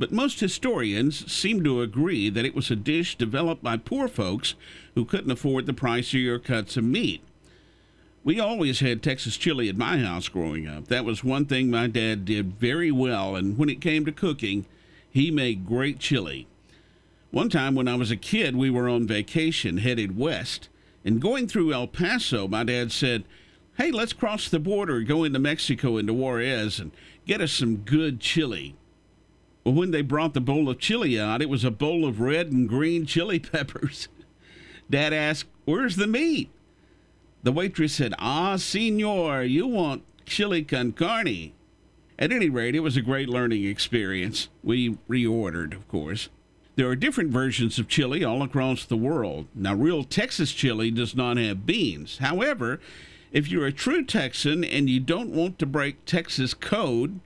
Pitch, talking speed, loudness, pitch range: 135 Hz, 180 wpm, -25 LUFS, 115-160 Hz